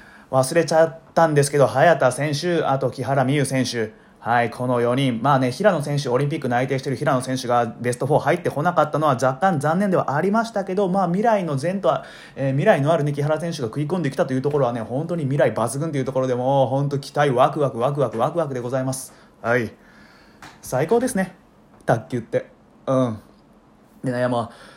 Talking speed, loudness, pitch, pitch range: 405 characters per minute, -21 LUFS, 140 Hz, 130-165 Hz